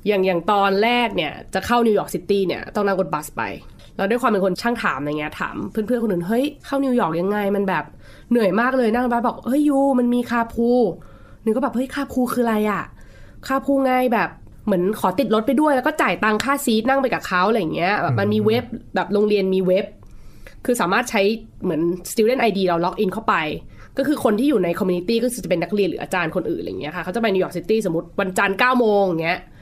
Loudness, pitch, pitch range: -20 LUFS, 215 Hz, 185-240 Hz